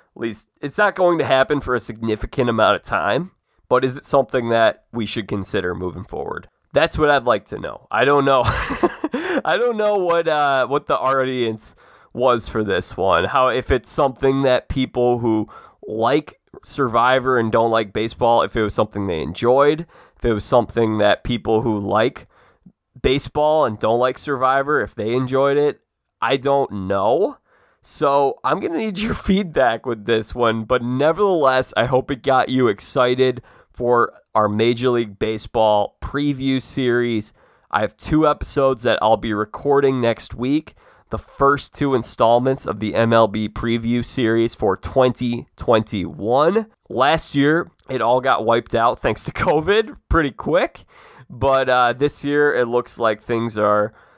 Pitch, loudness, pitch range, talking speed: 125 Hz, -19 LUFS, 110-140 Hz, 165 wpm